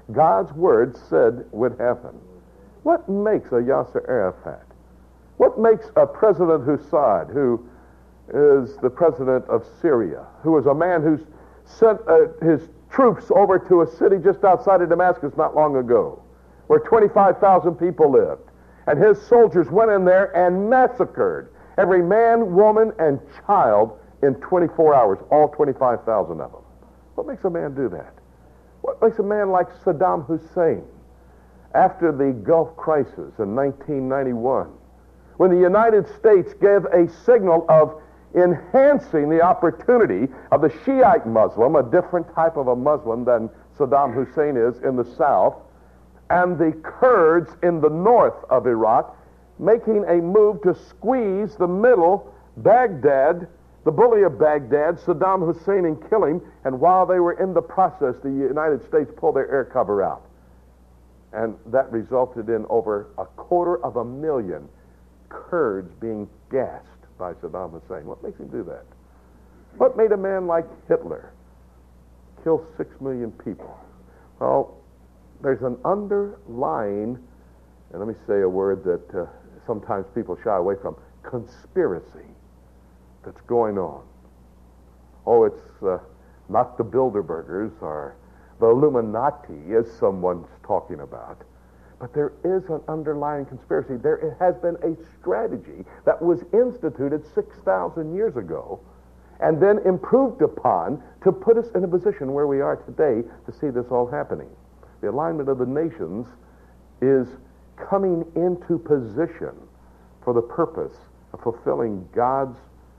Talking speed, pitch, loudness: 140 wpm, 155 Hz, -20 LUFS